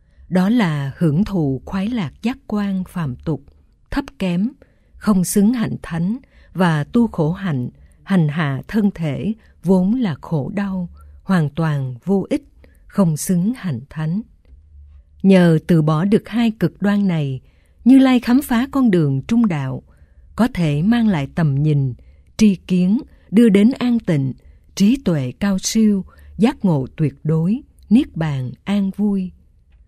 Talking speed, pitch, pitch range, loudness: 155 wpm, 180 Hz, 145-210 Hz, -18 LUFS